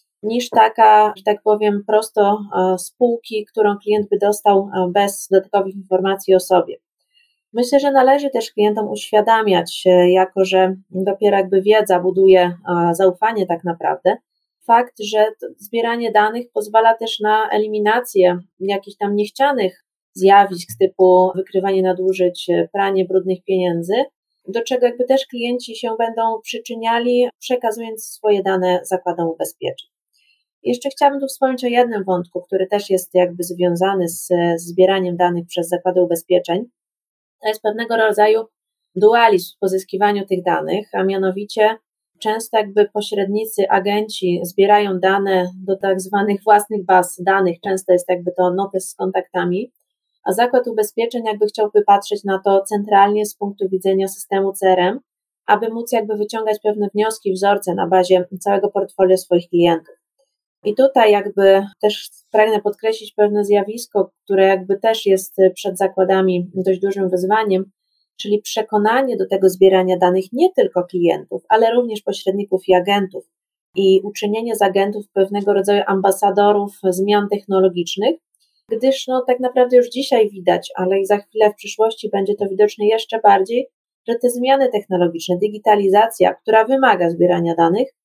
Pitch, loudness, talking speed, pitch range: 200 Hz, -17 LUFS, 140 wpm, 190-220 Hz